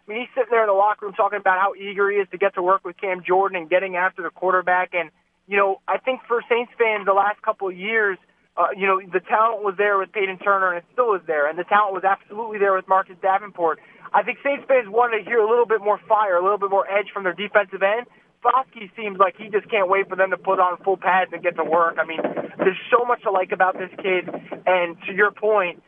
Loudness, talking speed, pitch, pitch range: -21 LUFS, 275 wpm, 195 Hz, 185-210 Hz